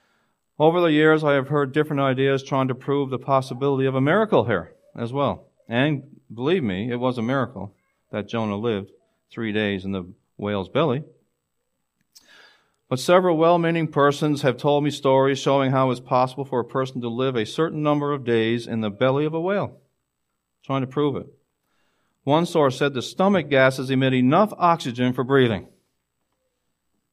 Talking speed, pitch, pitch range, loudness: 175 wpm, 135 Hz, 120-150 Hz, -22 LUFS